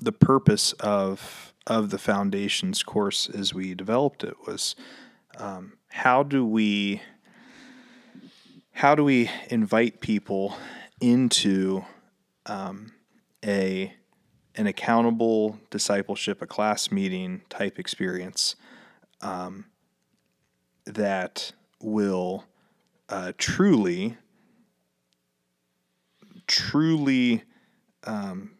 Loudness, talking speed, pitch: -25 LUFS, 80 wpm, 110 Hz